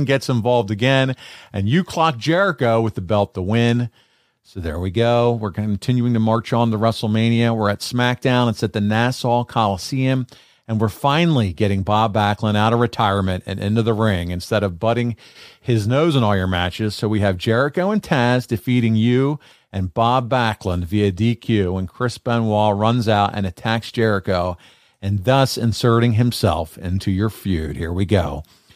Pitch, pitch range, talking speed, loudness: 115 Hz, 100-120 Hz, 175 wpm, -19 LUFS